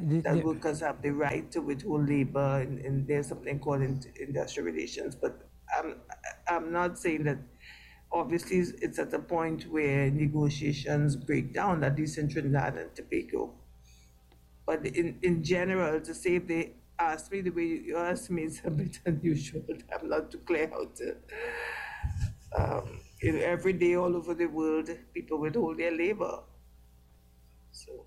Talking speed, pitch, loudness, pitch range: 155 wpm, 155 Hz, -32 LUFS, 140-170 Hz